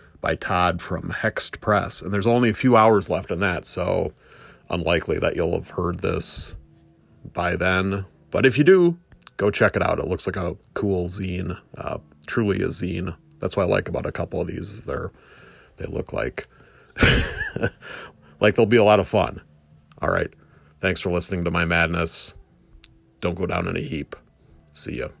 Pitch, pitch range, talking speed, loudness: 95 Hz, 85-105 Hz, 185 wpm, -22 LUFS